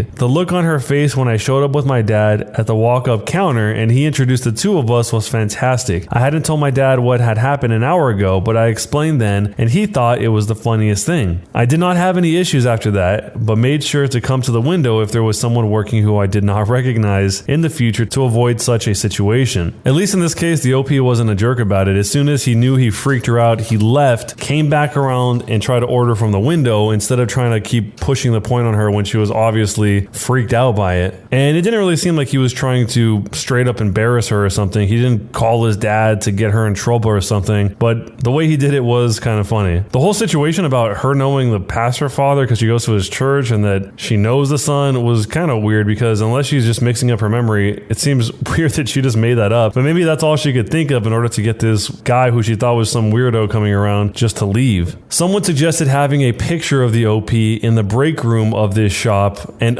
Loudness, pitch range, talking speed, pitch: -15 LUFS, 110-135 Hz, 255 wpm, 120 Hz